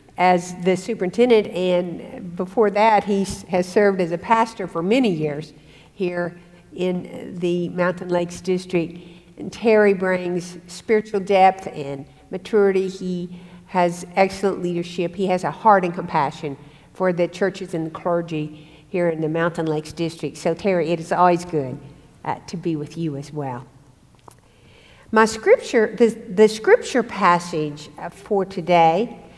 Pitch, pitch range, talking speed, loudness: 180 Hz, 165-195 Hz, 145 wpm, -21 LUFS